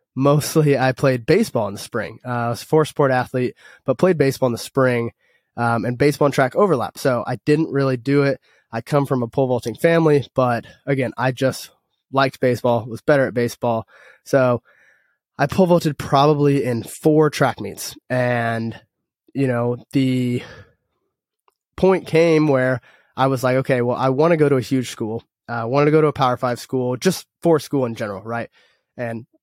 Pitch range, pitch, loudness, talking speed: 120-145 Hz, 130 Hz, -19 LUFS, 190 wpm